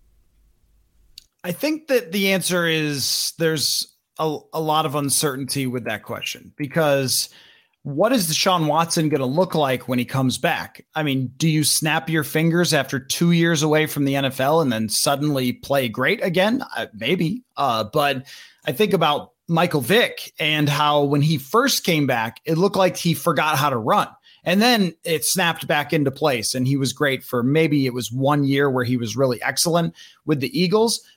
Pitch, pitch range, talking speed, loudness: 150 Hz, 135-170 Hz, 190 wpm, -20 LUFS